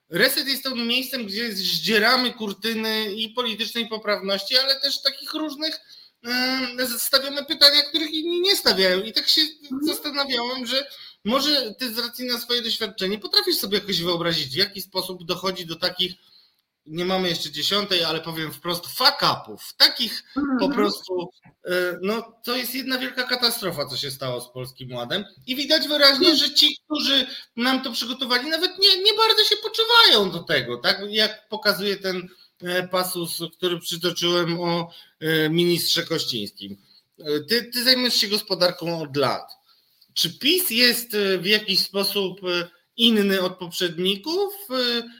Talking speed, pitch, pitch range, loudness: 145 wpm, 215 Hz, 180-265 Hz, -21 LUFS